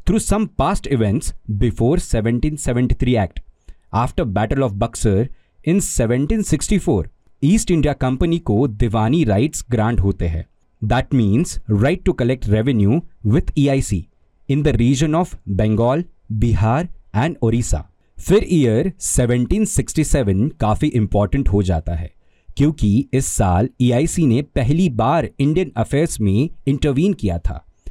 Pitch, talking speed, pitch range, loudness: 120 Hz, 145 wpm, 105-150 Hz, -18 LUFS